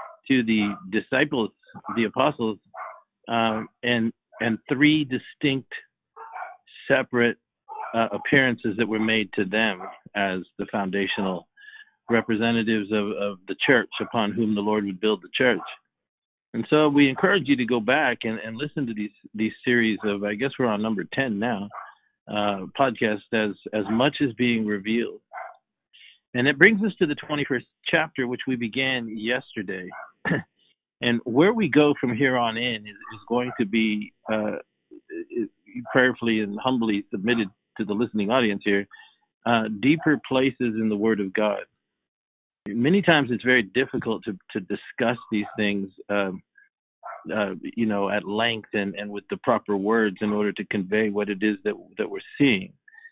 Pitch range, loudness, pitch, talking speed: 105-135 Hz, -24 LUFS, 115 Hz, 160 wpm